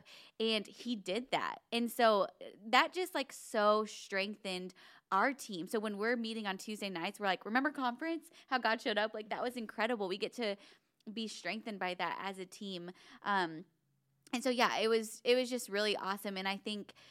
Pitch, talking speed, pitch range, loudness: 215 Hz, 195 wpm, 195-235 Hz, -36 LUFS